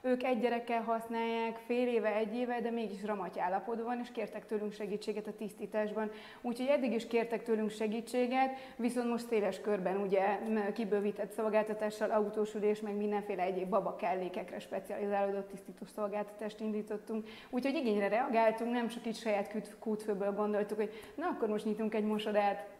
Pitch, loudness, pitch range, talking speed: 215 Hz, -35 LUFS, 210-230 Hz, 150 wpm